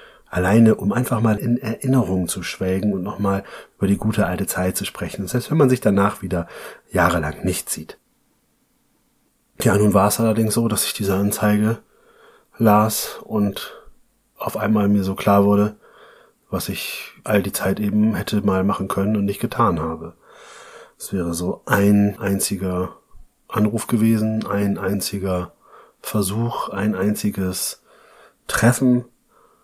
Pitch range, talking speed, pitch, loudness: 95-110 Hz, 145 wpm, 105 Hz, -20 LUFS